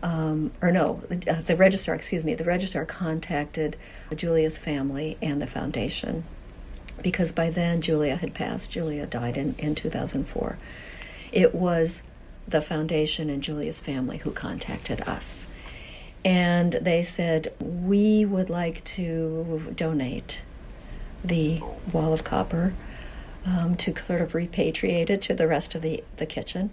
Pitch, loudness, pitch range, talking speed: 165 Hz, -26 LUFS, 155-175 Hz, 140 wpm